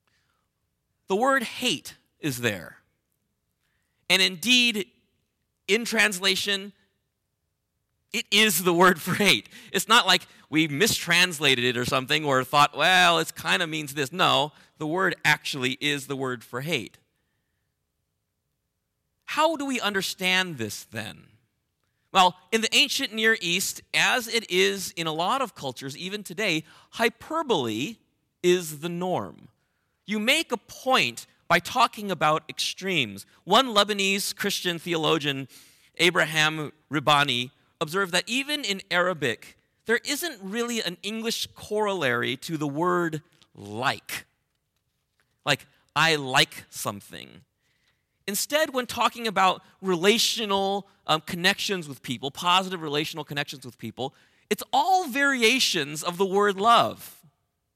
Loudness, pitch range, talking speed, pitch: -24 LUFS, 145-210 Hz, 125 wpm, 180 Hz